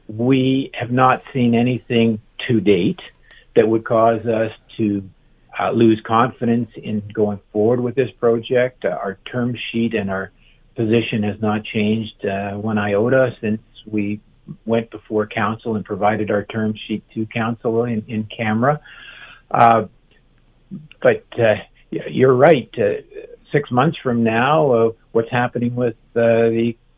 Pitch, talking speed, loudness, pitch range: 115 Hz, 145 wpm, -19 LUFS, 110-120 Hz